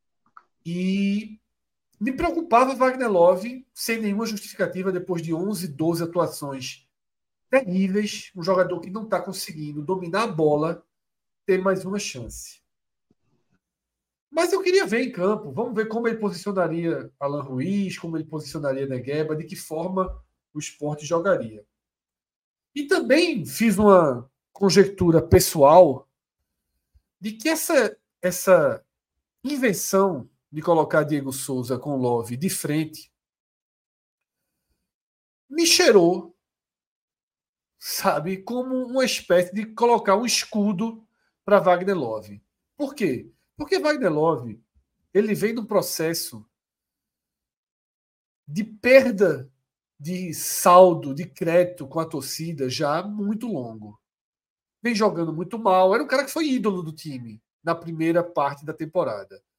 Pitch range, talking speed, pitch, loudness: 150-215 Hz, 120 wpm, 180 Hz, -22 LUFS